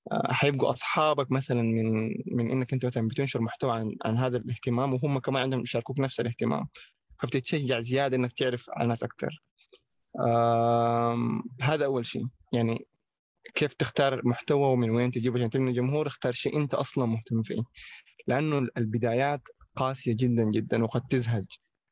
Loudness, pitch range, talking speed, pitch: -28 LUFS, 115-135 Hz, 145 wpm, 125 Hz